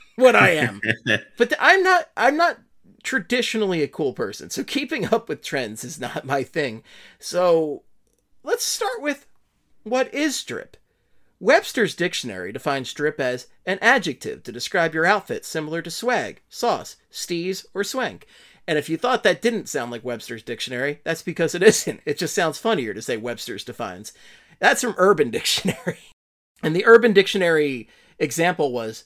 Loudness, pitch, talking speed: -21 LUFS, 175 Hz, 165 wpm